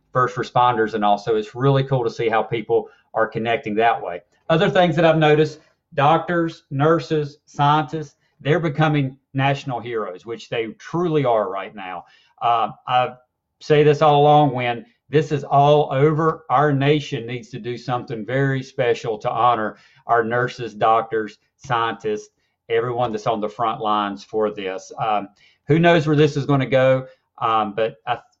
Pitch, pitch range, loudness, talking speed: 135 Hz, 115-150 Hz, -20 LUFS, 165 wpm